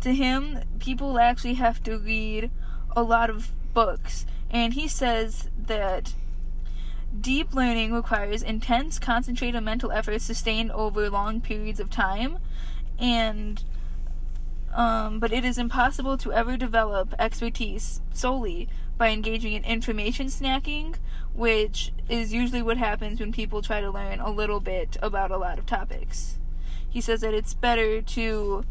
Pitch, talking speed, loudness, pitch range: 225 Hz, 140 wpm, -27 LUFS, 210-240 Hz